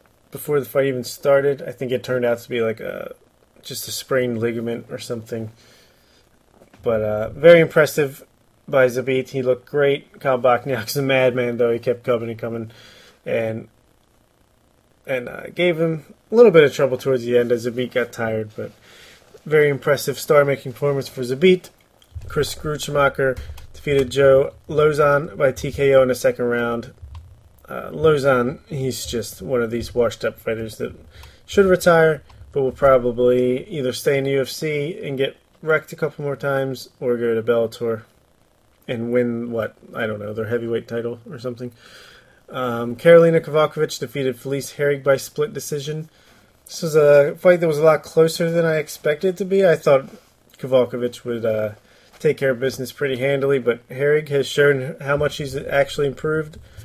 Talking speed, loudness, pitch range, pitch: 170 wpm, -19 LUFS, 120-145 Hz, 130 Hz